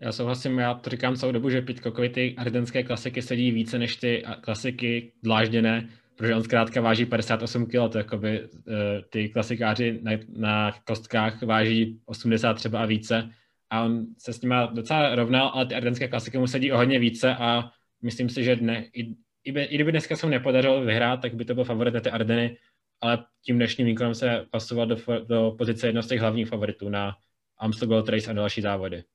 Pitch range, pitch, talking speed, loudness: 110-125 Hz, 115 Hz, 205 wpm, -26 LUFS